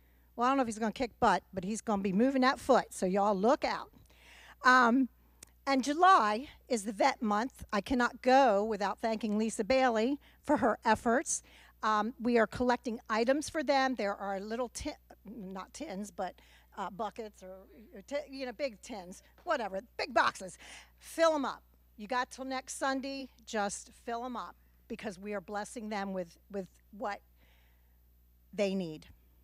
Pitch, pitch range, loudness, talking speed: 225 Hz, 200-260 Hz, -32 LUFS, 175 wpm